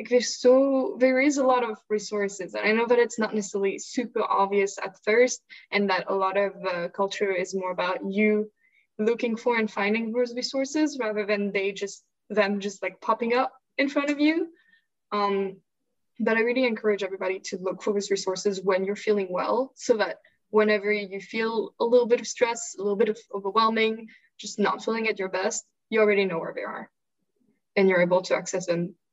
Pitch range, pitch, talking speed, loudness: 195-245 Hz, 215 Hz, 200 wpm, -25 LUFS